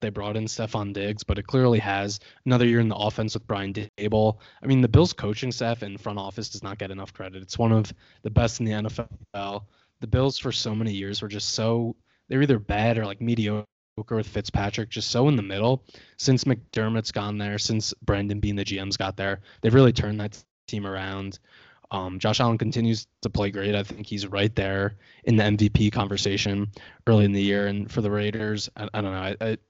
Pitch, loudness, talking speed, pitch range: 105 Hz, -25 LUFS, 220 wpm, 100-115 Hz